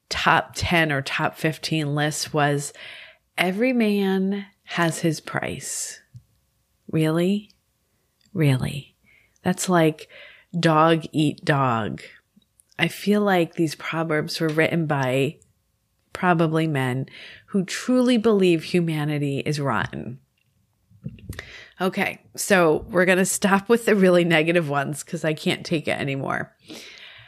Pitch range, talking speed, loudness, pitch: 150-185 Hz, 115 wpm, -22 LUFS, 165 Hz